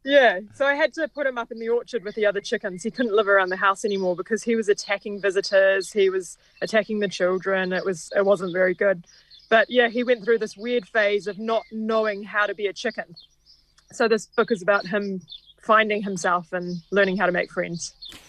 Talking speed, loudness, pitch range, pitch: 225 wpm, -23 LUFS, 190-225 Hz, 205 Hz